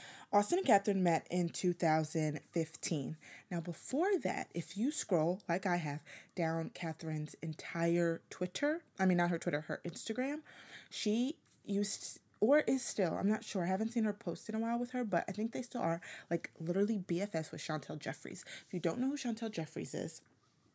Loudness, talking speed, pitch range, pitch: -36 LUFS, 185 wpm, 165-220 Hz, 180 Hz